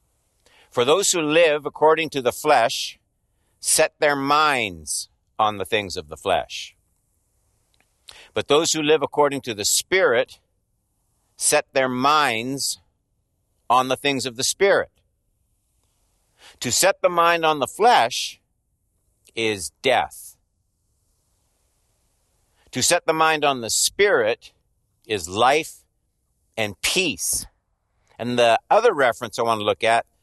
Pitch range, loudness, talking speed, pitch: 95-150 Hz, -20 LUFS, 125 wpm, 115 Hz